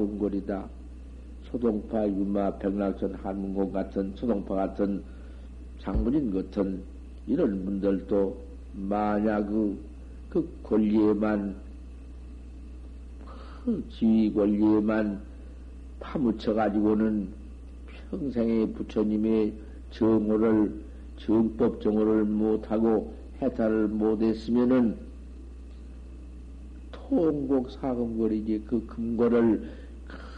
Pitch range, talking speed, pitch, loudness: 65-110 Hz, 180 characters per minute, 100 Hz, -27 LUFS